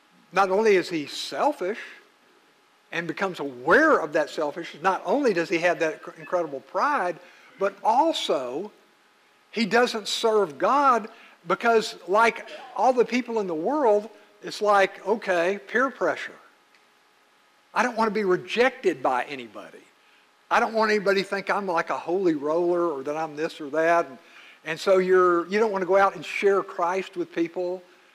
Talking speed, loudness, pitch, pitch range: 165 wpm, -24 LUFS, 195 Hz, 170-225 Hz